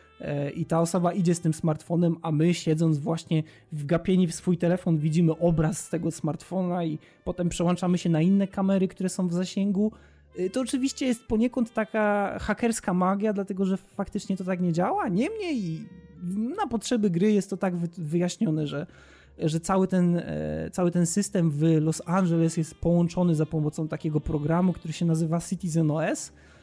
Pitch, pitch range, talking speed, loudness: 175 Hz, 160-190 Hz, 170 wpm, -26 LUFS